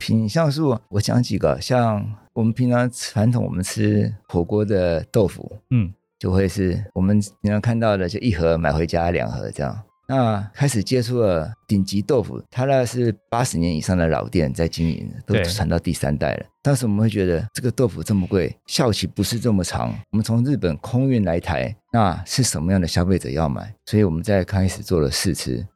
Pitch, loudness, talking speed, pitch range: 105 Hz, -21 LUFS, 295 characters per minute, 90-115 Hz